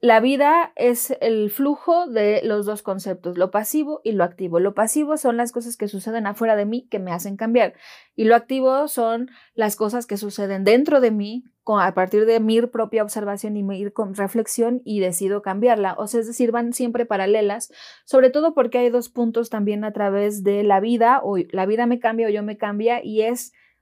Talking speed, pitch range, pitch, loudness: 205 wpm, 205-240 Hz, 220 Hz, -20 LUFS